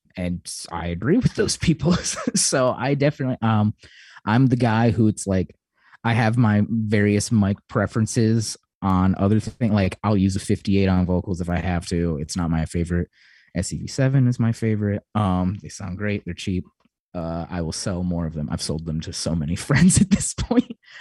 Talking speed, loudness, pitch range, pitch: 195 wpm, -22 LUFS, 90-115 Hz, 100 Hz